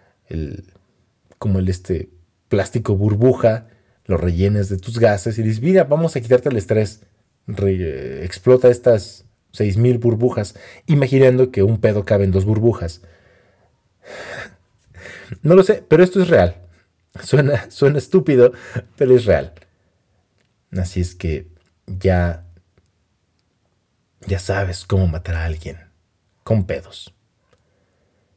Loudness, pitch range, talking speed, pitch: -17 LUFS, 90-120 Hz, 125 wpm, 100 Hz